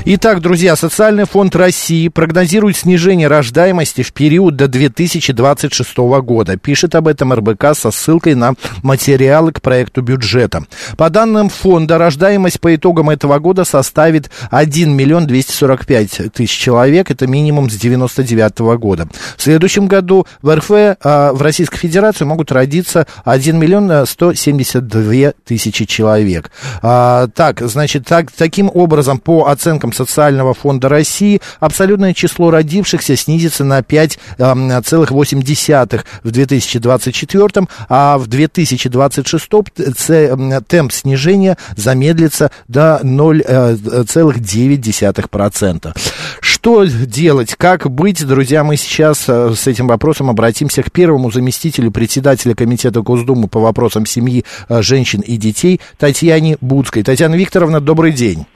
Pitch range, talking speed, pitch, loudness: 125-165 Hz, 115 wpm, 145 Hz, -11 LUFS